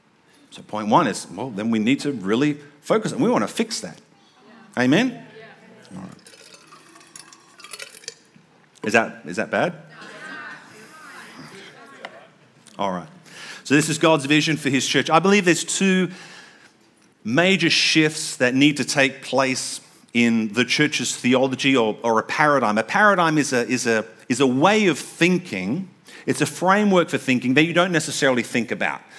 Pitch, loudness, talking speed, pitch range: 150 Hz, -20 LUFS, 155 wpm, 135-180 Hz